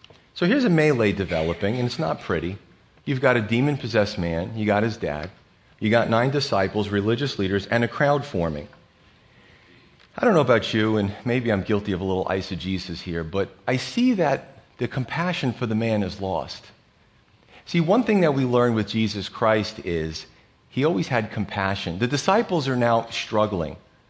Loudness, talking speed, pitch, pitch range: -23 LUFS, 180 wpm, 110 Hz, 95-125 Hz